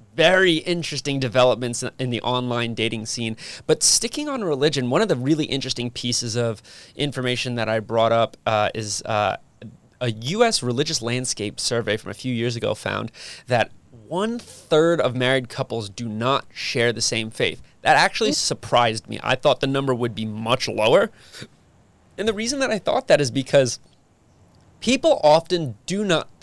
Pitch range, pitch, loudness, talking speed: 115-150 Hz, 125 Hz, -21 LUFS, 170 wpm